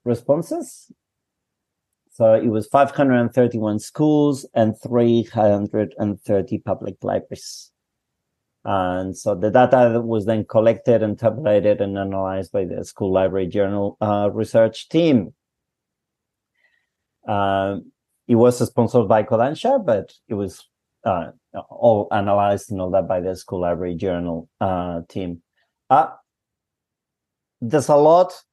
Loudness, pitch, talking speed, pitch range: -19 LUFS, 105 Hz, 120 wpm, 100-120 Hz